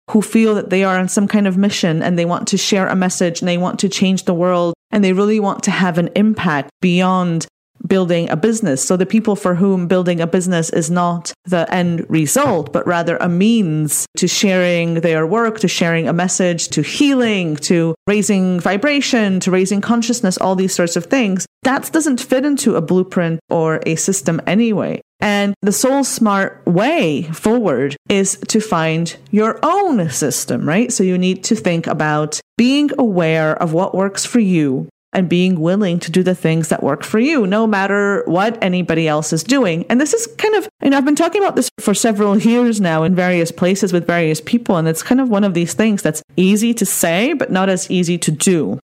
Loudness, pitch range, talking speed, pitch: -15 LUFS, 170-220 Hz, 205 wpm, 190 Hz